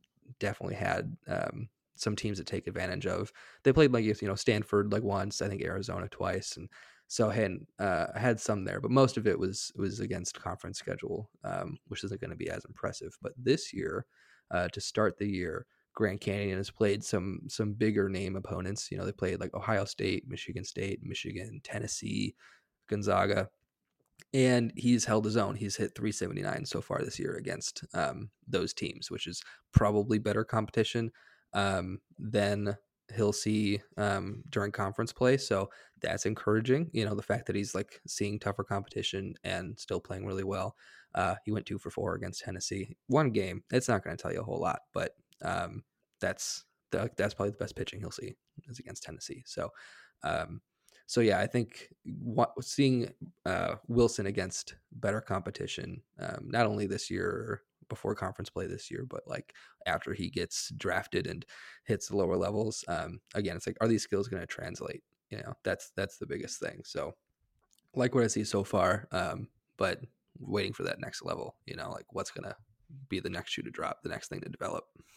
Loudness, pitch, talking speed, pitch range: -33 LUFS, 105 Hz, 190 wpm, 100-115 Hz